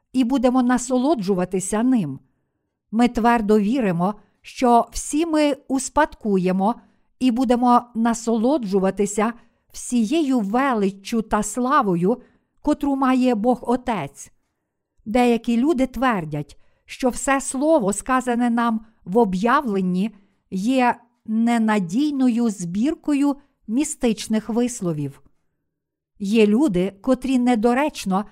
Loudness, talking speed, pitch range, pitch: -21 LUFS, 85 wpm, 205-255 Hz, 235 Hz